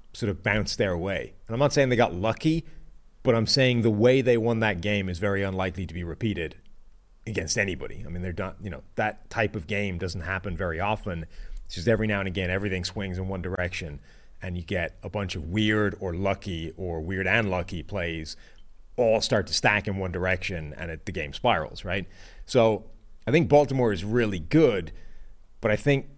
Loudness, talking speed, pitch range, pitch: -26 LUFS, 210 wpm, 90-110 Hz, 100 Hz